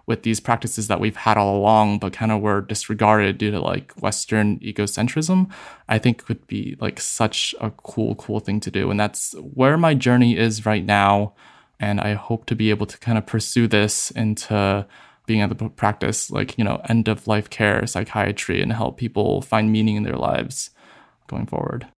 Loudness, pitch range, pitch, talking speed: -21 LUFS, 105-115 Hz, 110 Hz, 195 wpm